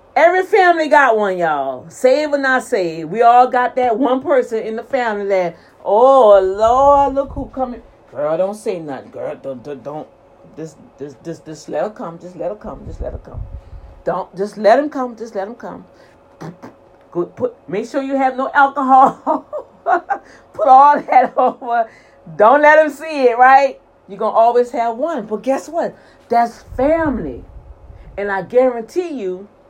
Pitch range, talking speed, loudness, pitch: 190-275 Hz, 170 wpm, -15 LUFS, 240 Hz